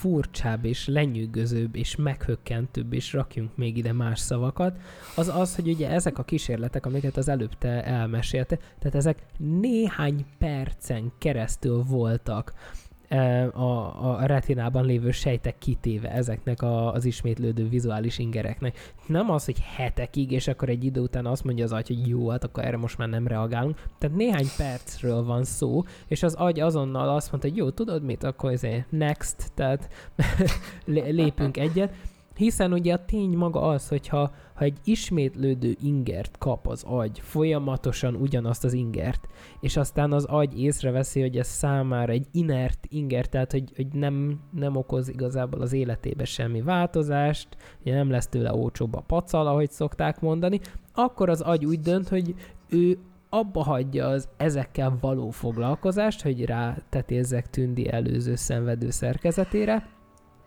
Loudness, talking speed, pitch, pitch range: -27 LUFS, 155 wpm, 130 Hz, 120-150 Hz